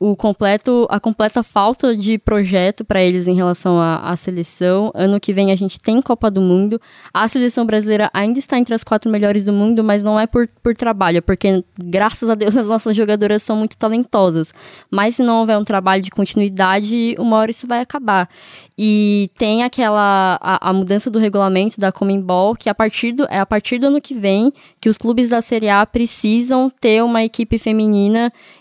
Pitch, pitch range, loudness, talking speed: 215 Hz, 195-230 Hz, -16 LUFS, 200 wpm